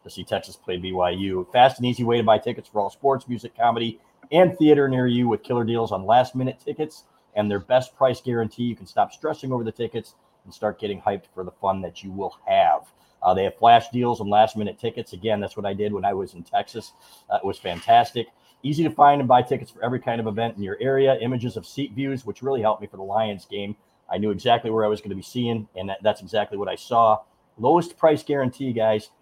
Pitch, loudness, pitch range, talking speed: 115 Hz, -23 LUFS, 105-130 Hz, 250 wpm